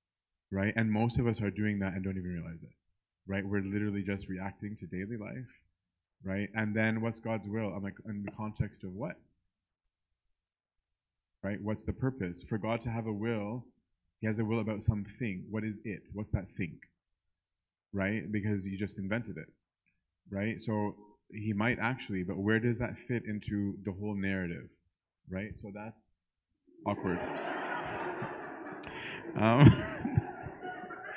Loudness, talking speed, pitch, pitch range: -34 LUFS, 155 wpm, 105 Hz, 95-110 Hz